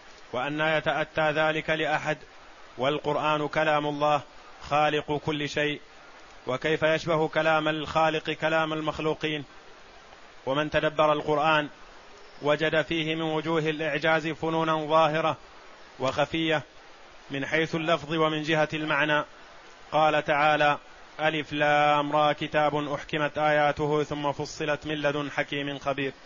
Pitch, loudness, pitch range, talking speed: 150 Hz, -26 LUFS, 145-155 Hz, 110 wpm